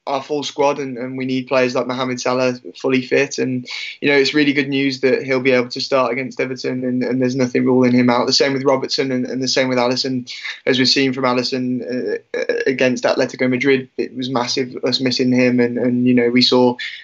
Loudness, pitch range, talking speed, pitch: -17 LUFS, 125-135 Hz, 235 wpm, 130 Hz